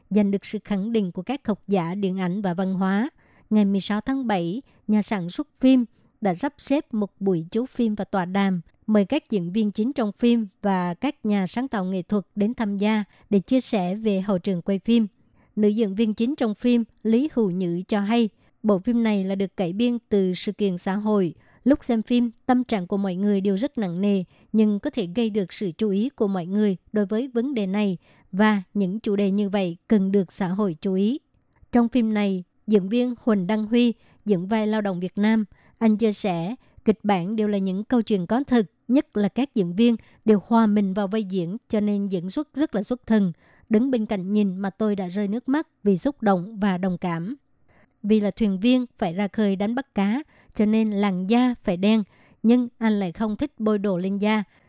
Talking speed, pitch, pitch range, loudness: 225 wpm, 210 Hz, 195-230 Hz, -23 LUFS